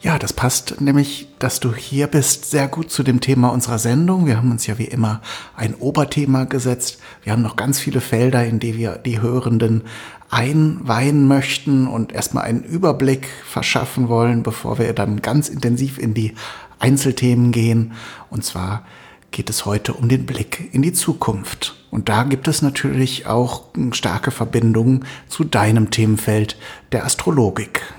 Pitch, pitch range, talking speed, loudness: 125 Hz, 115-140 Hz, 165 wpm, -18 LUFS